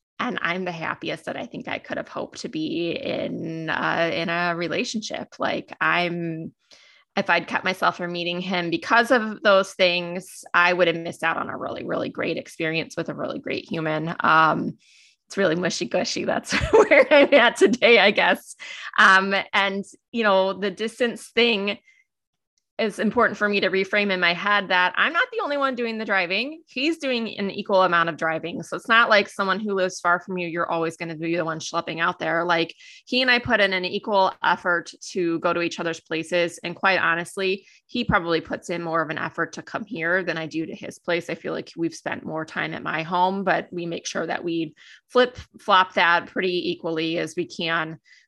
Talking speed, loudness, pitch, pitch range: 210 wpm, -22 LUFS, 185 Hz, 170-210 Hz